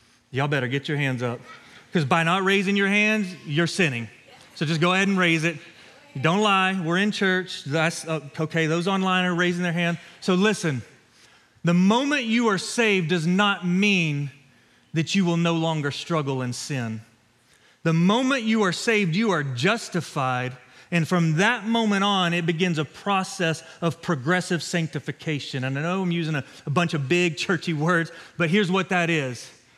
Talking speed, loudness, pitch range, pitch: 180 wpm, -23 LUFS, 150-190 Hz, 170 Hz